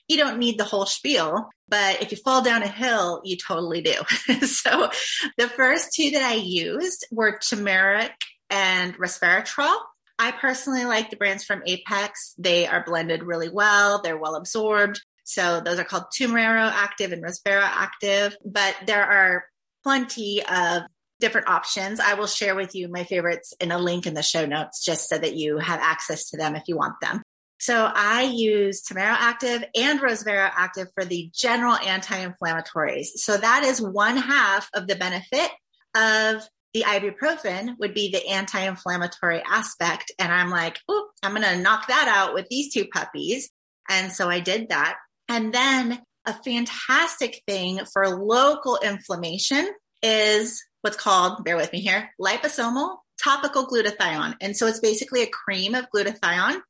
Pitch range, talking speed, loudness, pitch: 185-235 Hz, 165 wpm, -22 LUFS, 205 Hz